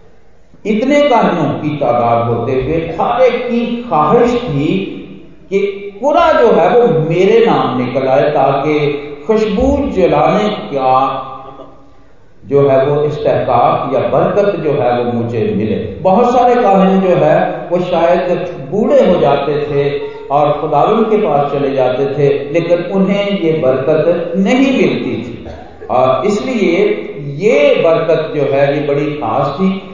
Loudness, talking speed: -12 LUFS, 140 wpm